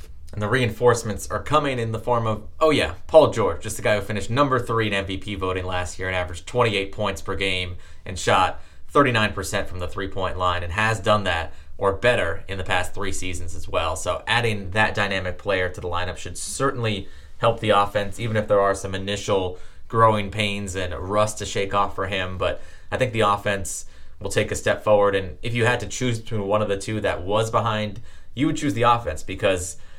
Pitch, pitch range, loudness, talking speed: 100 Hz, 90-110 Hz, -23 LUFS, 220 wpm